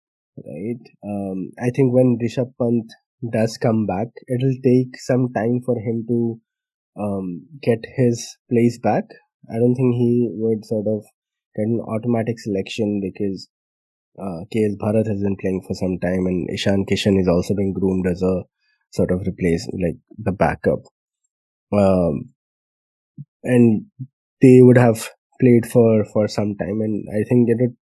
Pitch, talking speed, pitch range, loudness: 110 Hz, 160 wpm, 100-120 Hz, -19 LUFS